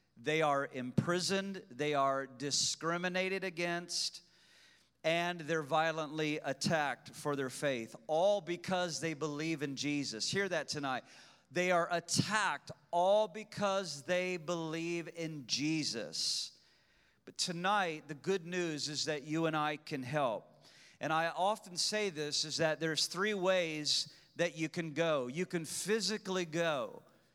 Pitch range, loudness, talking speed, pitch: 150-180 Hz, -35 LUFS, 135 wpm, 165 Hz